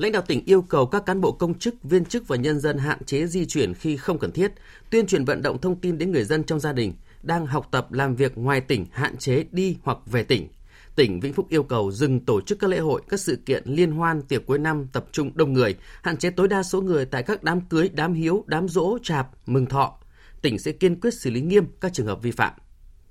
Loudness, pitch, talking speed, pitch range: -23 LUFS, 155 Hz, 260 wpm, 130-185 Hz